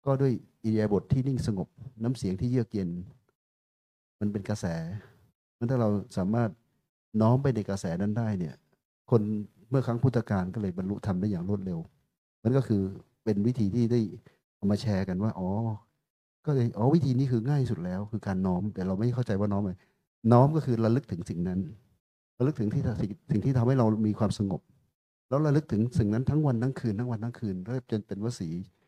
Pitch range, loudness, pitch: 100-125 Hz, -29 LUFS, 110 Hz